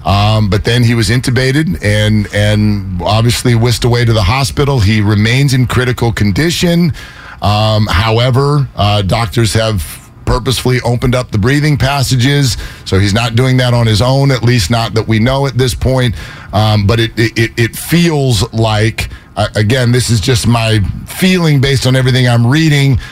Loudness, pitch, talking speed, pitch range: -11 LUFS, 120 Hz, 170 wpm, 105-130 Hz